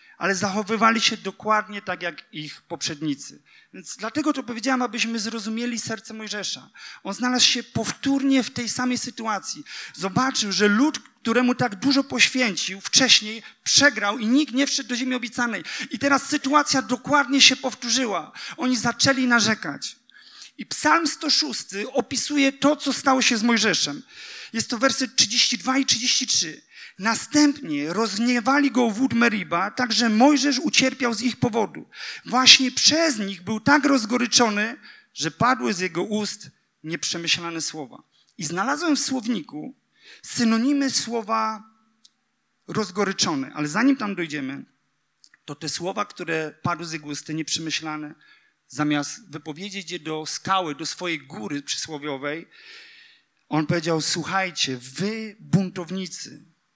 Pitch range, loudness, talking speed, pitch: 180-260 Hz, -22 LUFS, 130 wpm, 225 Hz